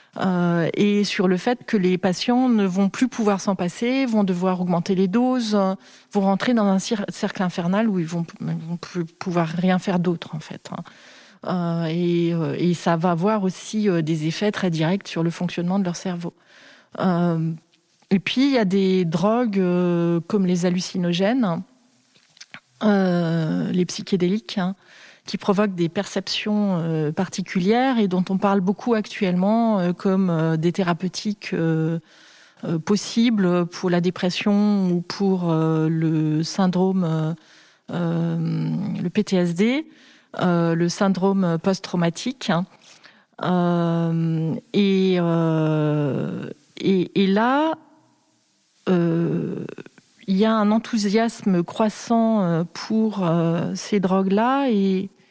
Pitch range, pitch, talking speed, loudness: 170-205 Hz, 185 Hz, 120 wpm, -22 LUFS